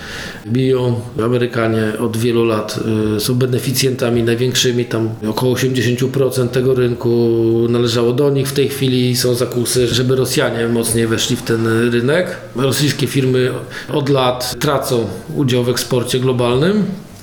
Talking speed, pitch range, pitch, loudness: 130 wpm, 115-130 Hz, 125 Hz, -16 LUFS